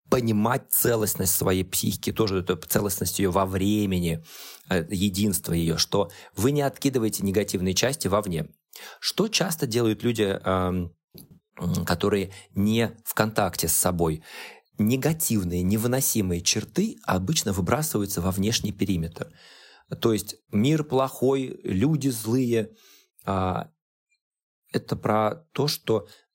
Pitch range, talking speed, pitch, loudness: 95-125 Hz, 105 wpm, 105 Hz, -25 LUFS